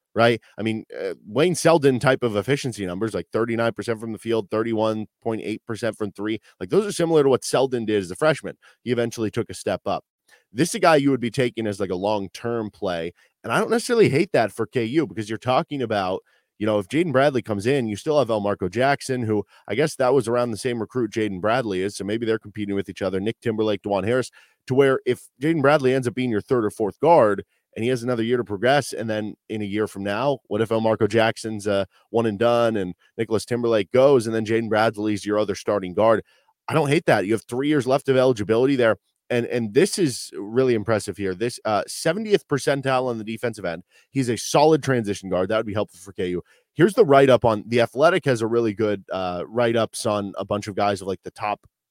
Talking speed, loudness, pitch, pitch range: 235 wpm, -22 LUFS, 115 Hz, 105-125 Hz